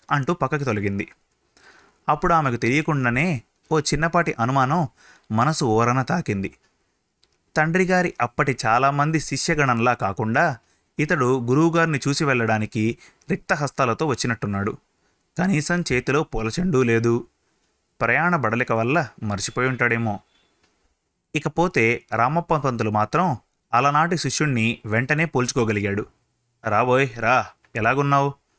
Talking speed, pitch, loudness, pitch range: 90 wpm, 130 Hz, -21 LUFS, 115-155 Hz